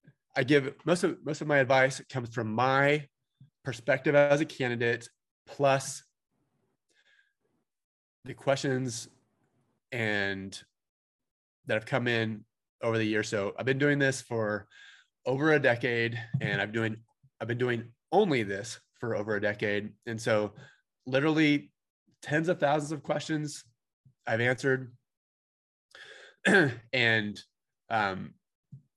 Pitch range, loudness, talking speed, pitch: 115-145 Hz, -29 LUFS, 120 wpm, 130 Hz